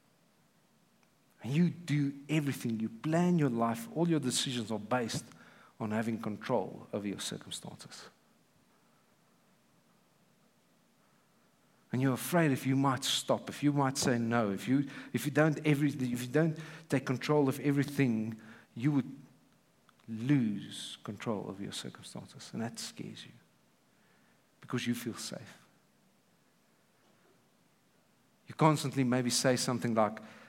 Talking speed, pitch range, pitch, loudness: 125 wpm, 115-145 Hz, 130 Hz, -33 LUFS